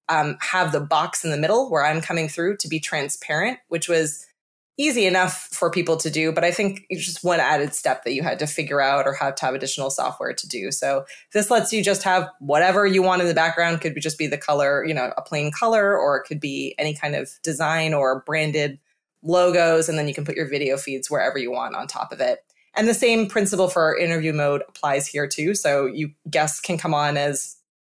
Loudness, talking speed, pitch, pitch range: -22 LUFS, 235 wpm, 160 Hz, 145-185 Hz